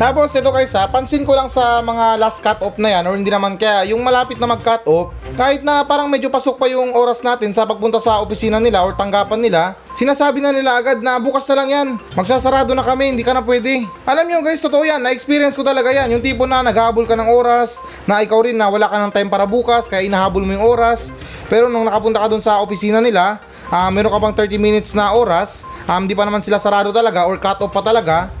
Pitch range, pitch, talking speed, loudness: 210-260 Hz, 230 Hz, 245 wpm, -15 LUFS